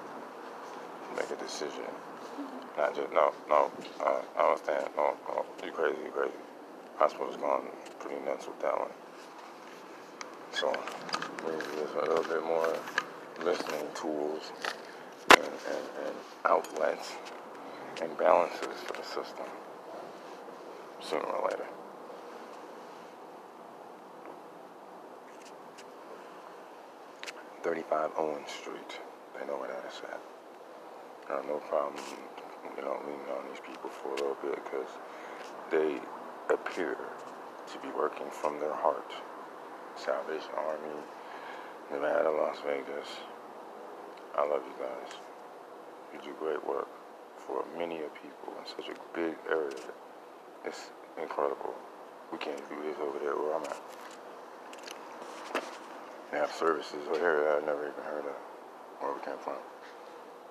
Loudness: -34 LUFS